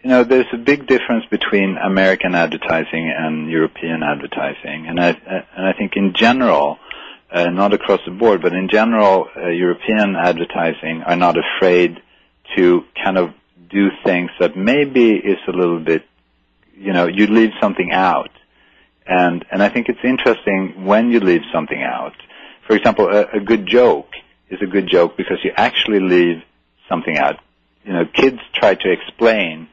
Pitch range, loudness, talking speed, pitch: 80-105 Hz, -16 LUFS, 170 wpm, 95 Hz